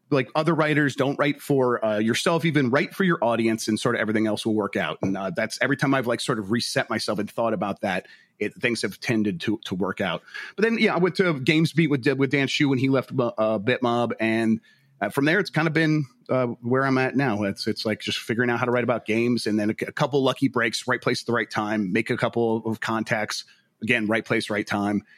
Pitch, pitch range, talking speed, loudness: 120 Hz, 110-140 Hz, 255 wpm, -24 LUFS